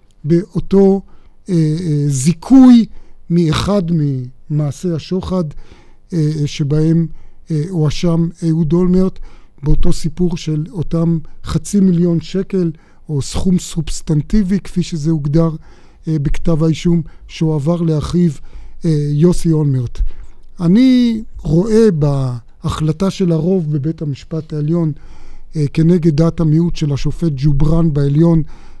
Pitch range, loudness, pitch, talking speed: 150-175 Hz, -15 LUFS, 165 Hz, 105 wpm